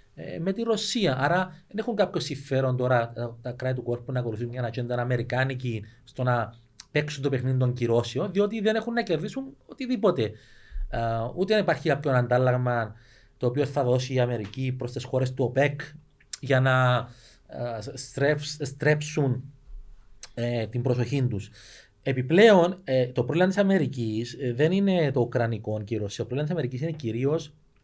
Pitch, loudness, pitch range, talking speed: 130 Hz, -26 LUFS, 120-150 Hz, 150 wpm